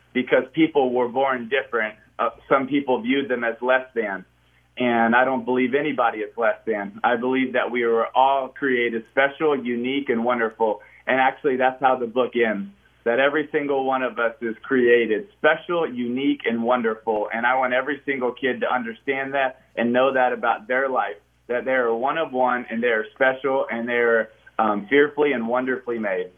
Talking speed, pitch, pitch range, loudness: 190 wpm, 125 Hz, 120-135 Hz, -22 LUFS